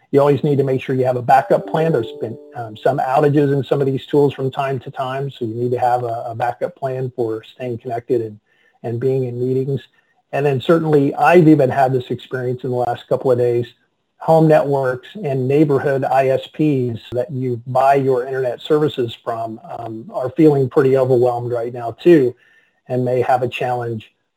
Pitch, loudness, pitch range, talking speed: 130 Hz, -17 LUFS, 125-140 Hz, 200 wpm